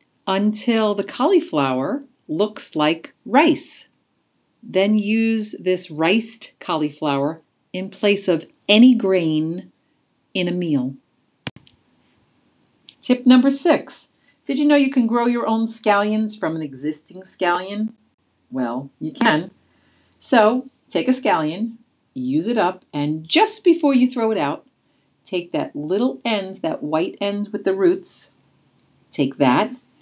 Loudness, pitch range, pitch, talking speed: -19 LUFS, 175-255 Hz, 210 Hz, 130 wpm